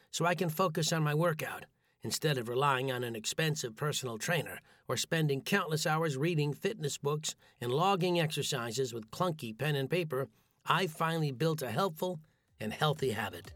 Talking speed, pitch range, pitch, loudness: 170 wpm, 130-165 Hz, 150 Hz, -33 LUFS